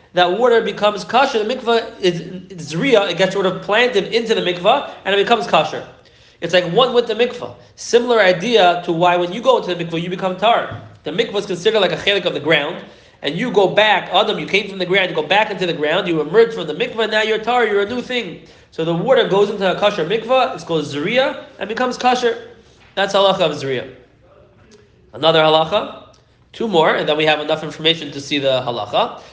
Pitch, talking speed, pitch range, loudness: 195 Hz, 225 wpm, 170-230 Hz, -16 LUFS